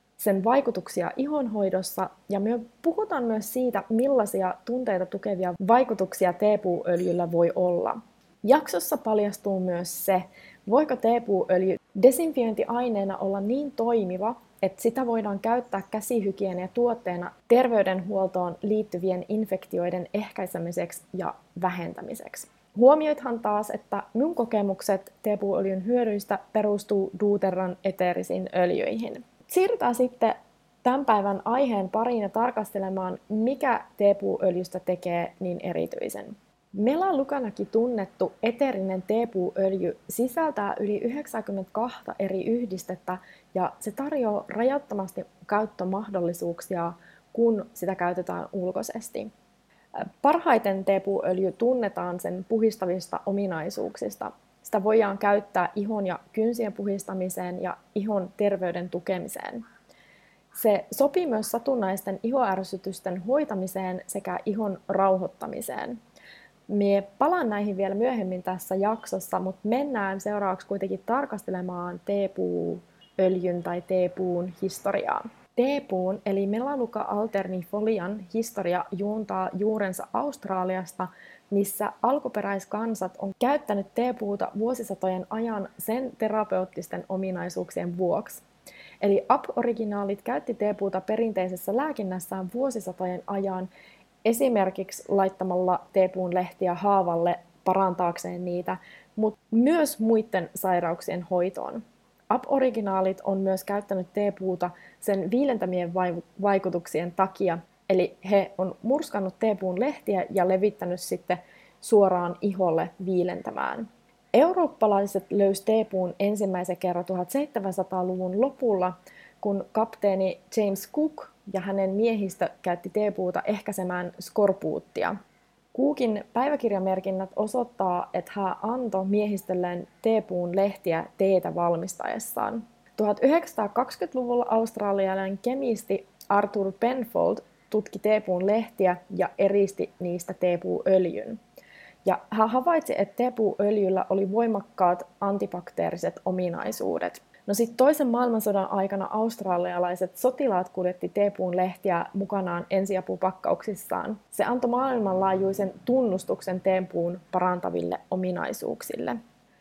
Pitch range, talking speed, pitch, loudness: 185-225 Hz, 95 wpm, 200 Hz, -27 LUFS